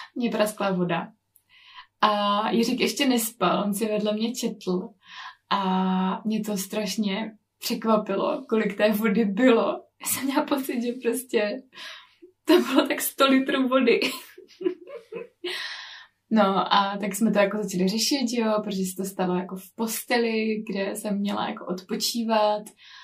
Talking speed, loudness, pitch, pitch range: 140 wpm, -25 LUFS, 220 Hz, 205-260 Hz